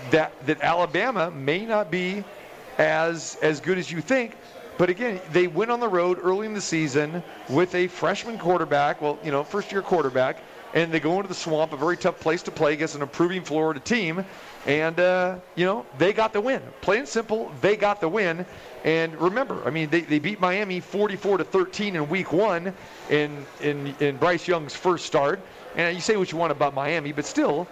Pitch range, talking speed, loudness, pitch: 155-190 Hz, 210 wpm, -24 LUFS, 175 Hz